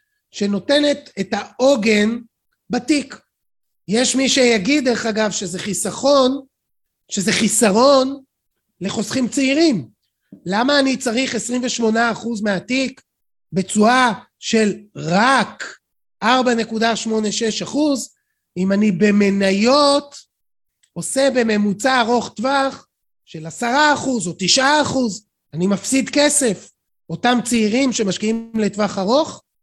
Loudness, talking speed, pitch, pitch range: -17 LUFS, 85 wpm, 235 Hz, 205-265 Hz